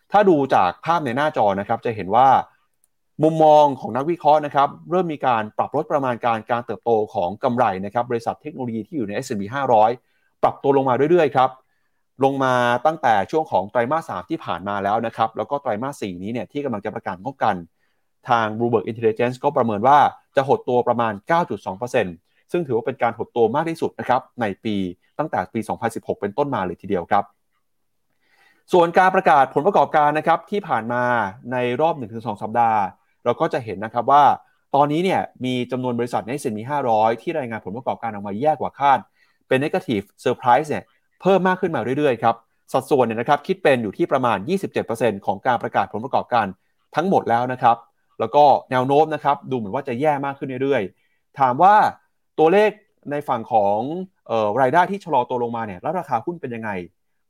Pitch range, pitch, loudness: 115-155 Hz, 130 Hz, -20 LUFS